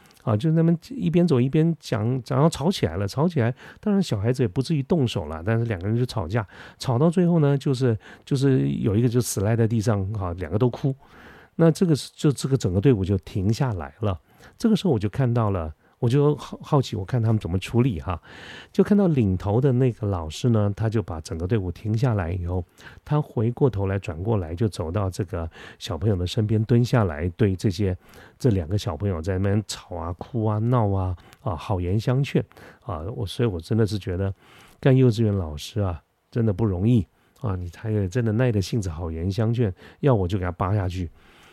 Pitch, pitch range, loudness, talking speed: 110 Hz, 95-130 Hz, -24 LUFS, 310 characters per minute